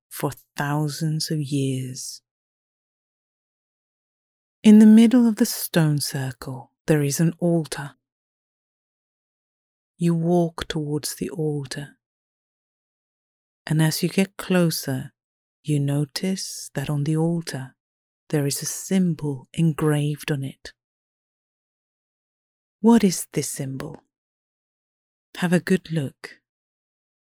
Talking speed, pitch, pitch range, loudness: 100 wpm, 155 Hz, 140-170 Hz, -22 LUFS